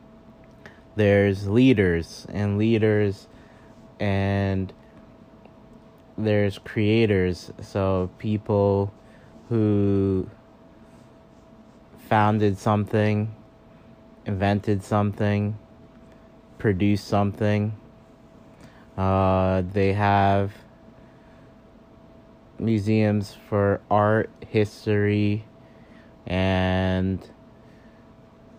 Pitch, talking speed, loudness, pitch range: 105 Hz, 50 wpm, -23 LUFS, 100-110 Hz